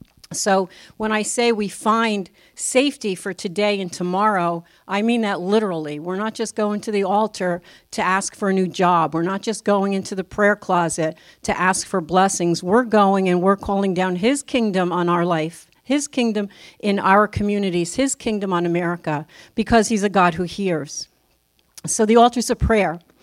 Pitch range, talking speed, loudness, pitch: 175-215 Hz, 185 wpm, -20 LUFS, 195 Hz